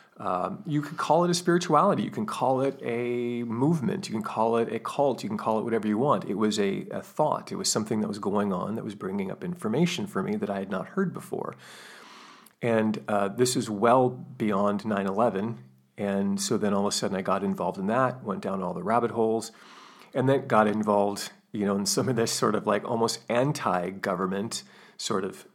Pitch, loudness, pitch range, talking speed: 115 Hz, -27 LUFS, 105-155 Hz, 220 wpm